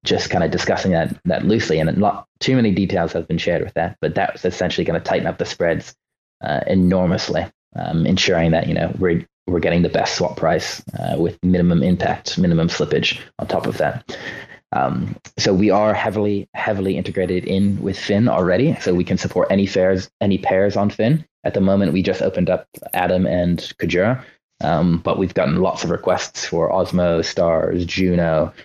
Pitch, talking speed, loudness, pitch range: 95 Hz, 195 wpm, -19 LUFS, 90-100 Hz